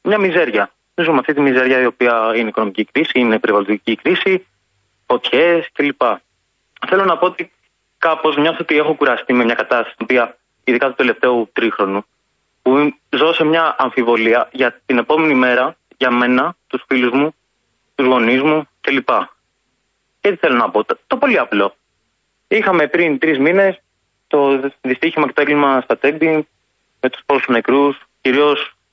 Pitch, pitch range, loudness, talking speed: 135 Hz, 125-155 Hz, -15 LUFS, 170 wpm